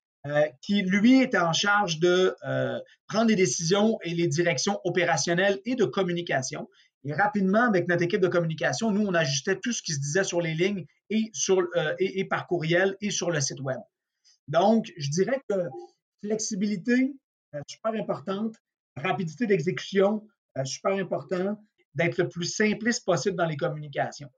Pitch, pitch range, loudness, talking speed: 185 Hz, 170-210 Hz, -26 LUFS, 170 wpm